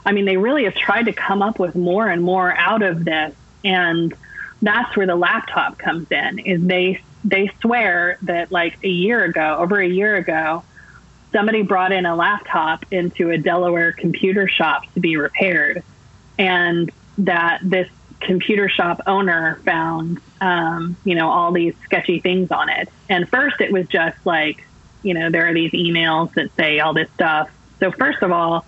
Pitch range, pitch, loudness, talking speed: 165-195 Hz, 180 Hz, -18 LUFS, 180 wpm